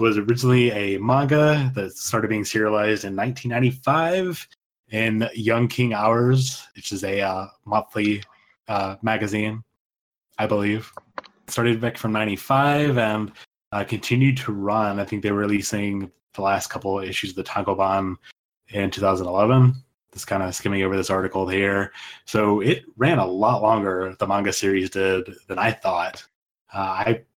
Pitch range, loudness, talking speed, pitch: 100-120 Hz, -22 LUFS, 155 wpm, 105 Hz